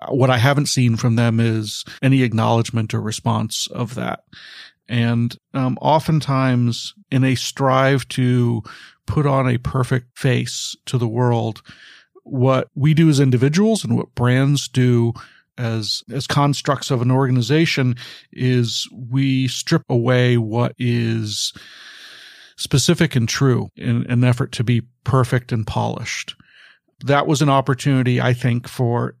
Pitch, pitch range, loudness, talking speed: 125 Hz, 120-135 Hz, -19 LUFS, 140 wpm